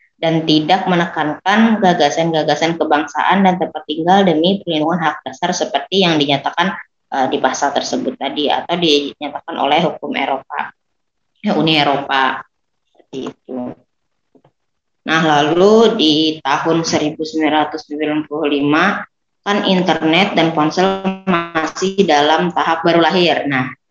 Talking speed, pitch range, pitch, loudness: 110 wpm, 150-175 Hz, 160 Hz, -15 LUFS